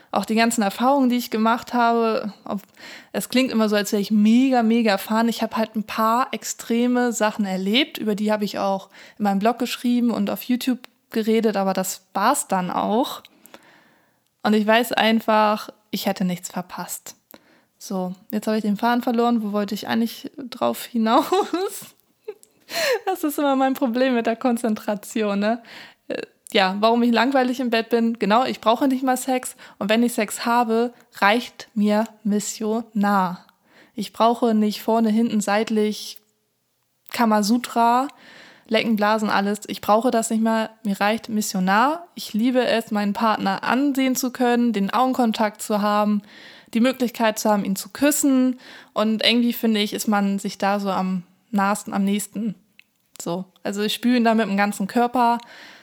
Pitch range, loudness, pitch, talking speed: 210-245 Hz, -21 LUFS, 225 Hz, 165 wpm